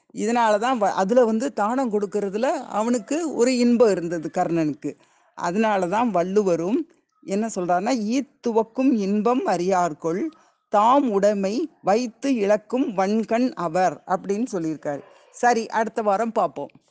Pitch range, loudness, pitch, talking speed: 190-255 Hz, -22 LUFS, 220 Hz, 115 wpm